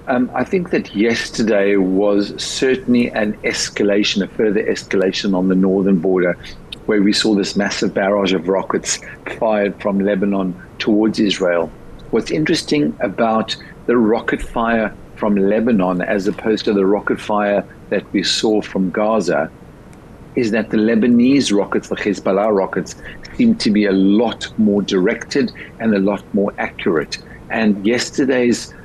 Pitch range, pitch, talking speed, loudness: 95-115 Hz, 105 Hz, 145 wpm, -17 LUFS